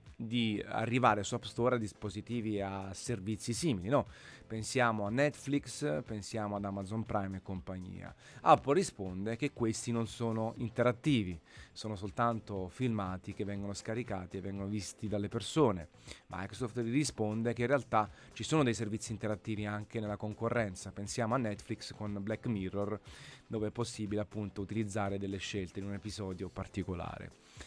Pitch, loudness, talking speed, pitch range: 105 Hz, -36 LUFS, 150 wpm, 100-120 Hz